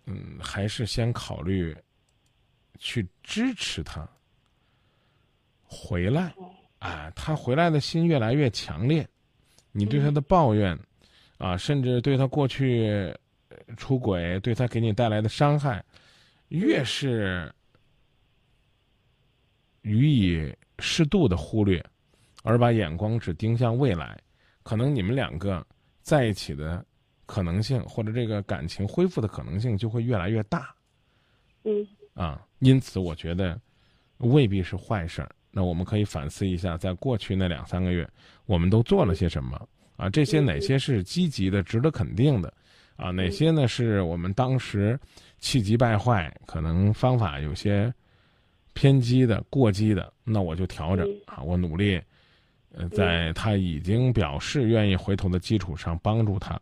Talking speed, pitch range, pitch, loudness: 210 characters per minute, 95-130 Hz, 110 Hz, -26 LUFS